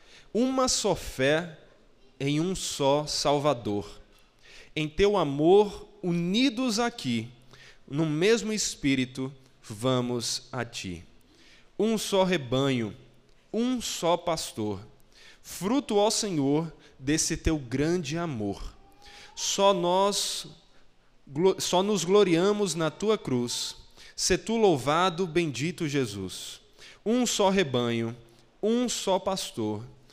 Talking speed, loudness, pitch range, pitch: 100 wpm, -27 LUFS, 130-200 Hz, 160 Hz